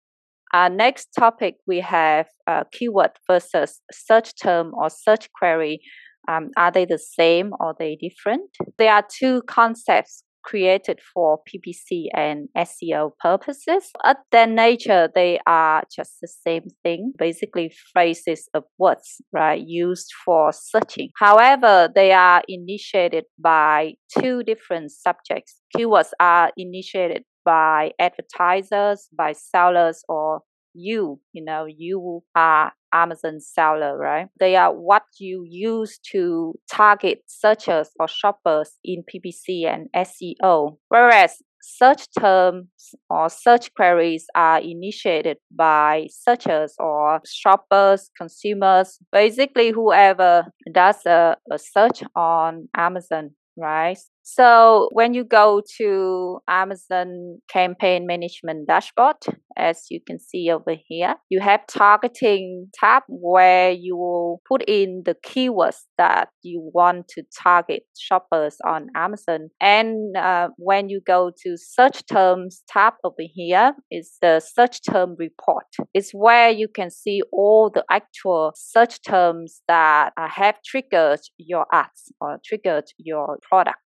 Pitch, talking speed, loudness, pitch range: 185 Hz, 125 wpm, -18 LUFS, 165-215 Hz